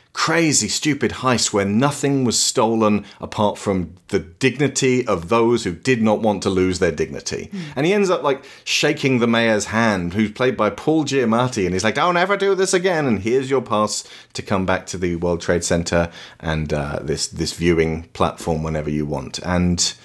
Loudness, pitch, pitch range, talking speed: -19 LUFS, 105 Hz, 90-135 Hz, 195 wpm